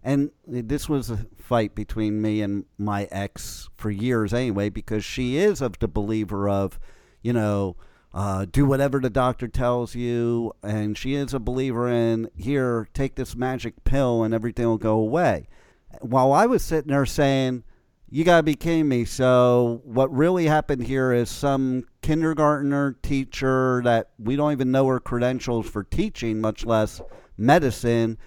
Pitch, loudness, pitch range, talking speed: 120 Hz, -23 LUFS, 110-135 Hz, 165 wpm